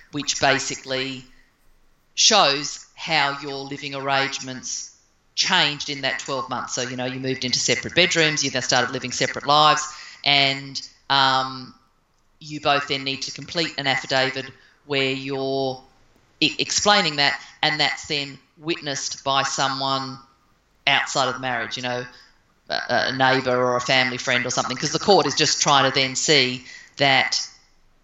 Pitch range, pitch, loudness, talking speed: 130-140 Hz, 135 Hz, -21 LUFS, 155 wpm